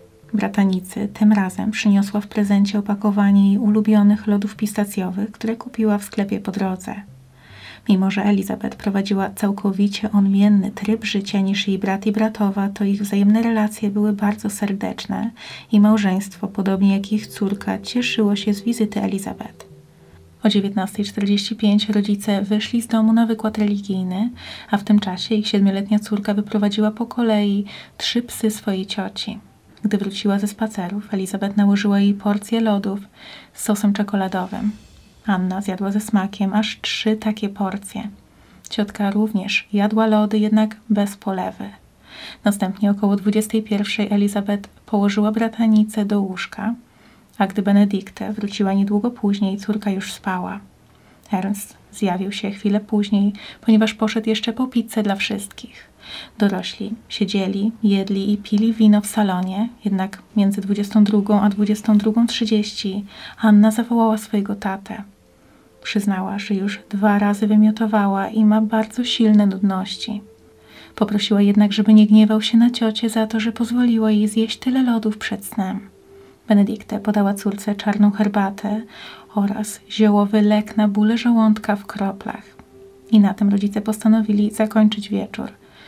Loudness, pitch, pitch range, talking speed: -19 LUFS, 210 Hz, 200-215 Hz, 135 wpm